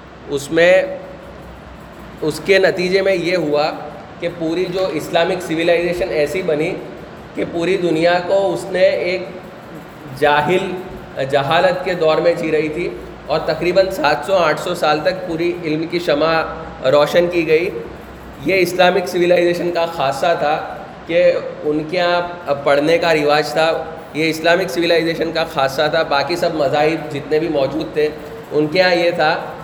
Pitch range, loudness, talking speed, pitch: 155-180 Hz, -17 LUFS, 160 wpm, 170 Hz